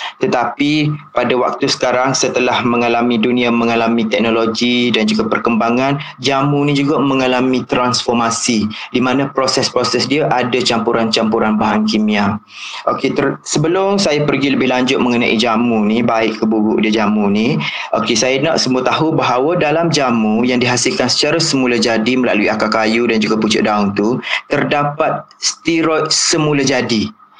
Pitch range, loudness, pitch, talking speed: 115-140 Hz, -14 LUFS, 125 Hz, 145 wpm